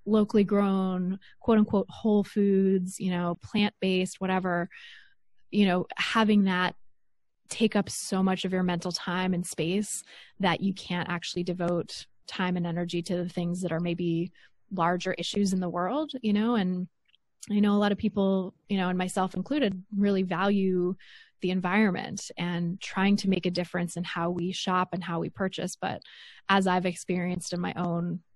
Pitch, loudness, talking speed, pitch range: 185 Hz, -28 LUFS, 175 wpm, 175-200 Hz